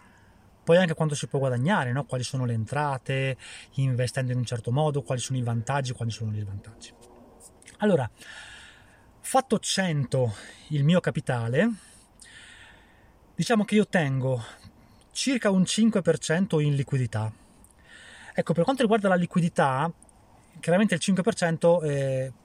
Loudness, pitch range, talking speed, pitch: -26 LUFS, 120-175 Hz, 130 wpm, 140 Hz